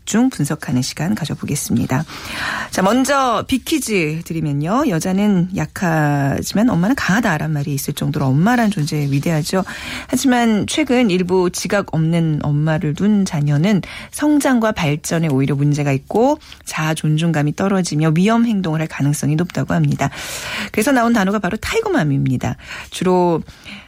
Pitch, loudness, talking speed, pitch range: 175 Hz, -17 LUFS, 330 characters per minute, 150-220 Hz